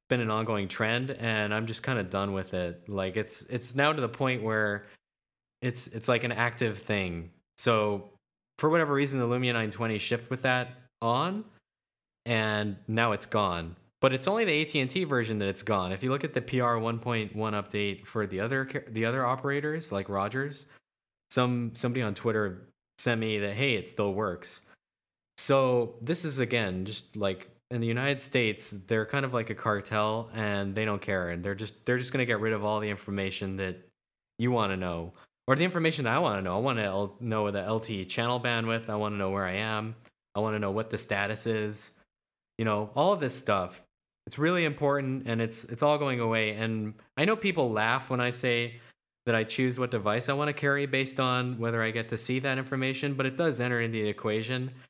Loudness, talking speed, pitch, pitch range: -29 LUFS, 210 wpm, 115 Hz, 105-130 Hz